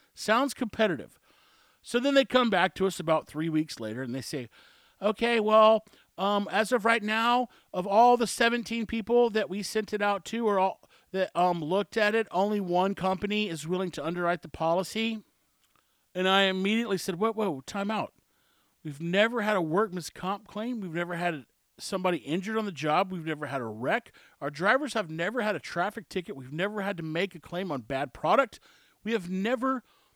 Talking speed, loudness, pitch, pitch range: 195 wpm, -28 LUFS, 195 Hz, 175-220 Hz